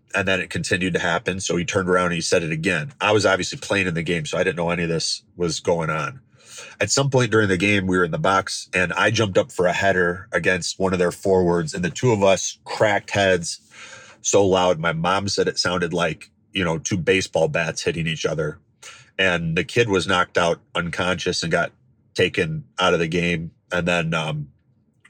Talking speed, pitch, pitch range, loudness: 225 wpm, 90 Hz, 85-95 Hz, -21 LUFS